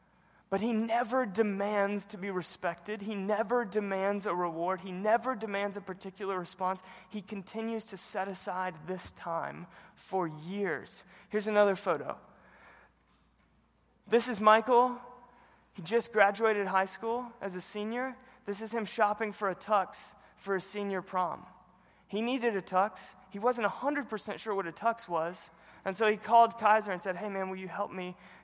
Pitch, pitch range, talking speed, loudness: 200 Hz, 185-220 Hz, 160 wpm, -32 LUFS